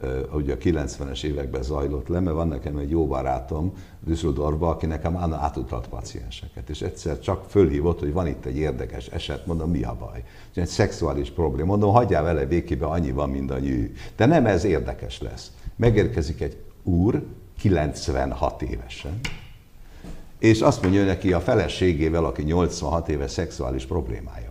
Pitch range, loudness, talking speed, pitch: 75-95 Hz, -24 LUFS, 160 wpm, 85 Hz